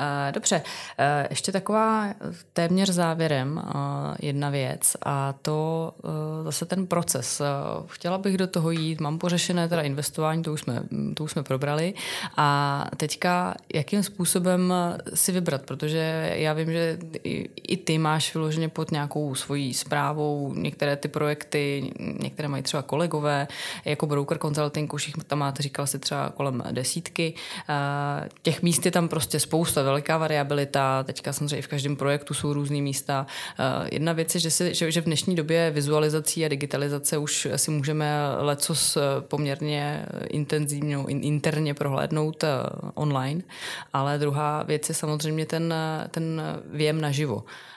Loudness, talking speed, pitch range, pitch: -26 LUFS, 140 wpm, 145-165 Hz, 150 Hz